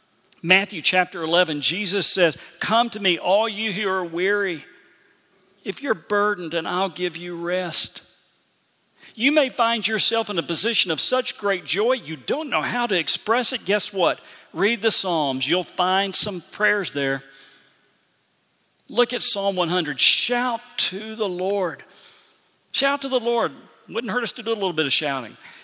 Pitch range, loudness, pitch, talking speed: 175-225 Hz, -21 LUFS, 195 Hz, 165 wpm